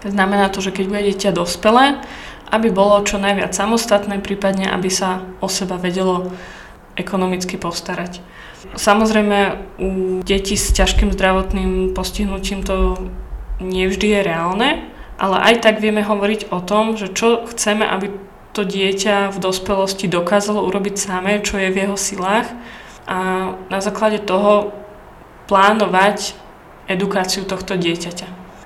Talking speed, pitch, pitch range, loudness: 130 wpm, 195 Hz, 185-205 Hz, -17 LUFS